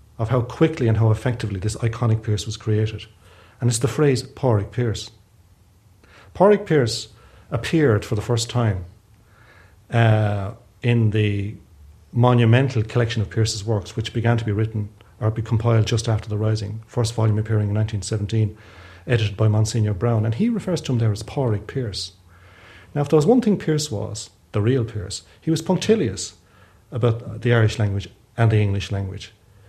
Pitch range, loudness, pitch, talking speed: 105-120 Hz, -21 LUFS, 110 Hz, 170 wpm